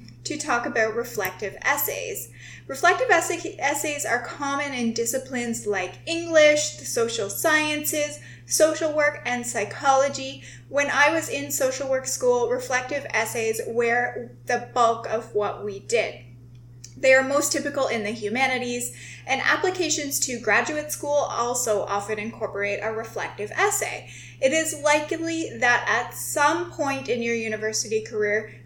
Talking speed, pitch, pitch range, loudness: 140 wpm, 260 Hz, 215-300 Hz, -24 LUFS